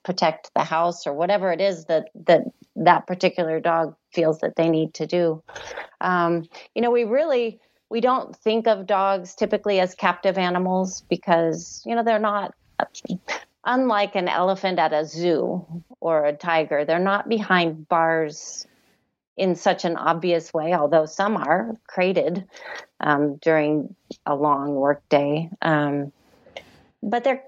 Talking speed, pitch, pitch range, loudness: 150 wpm, 175 Hz, 160-200 Hz, -22 LUFS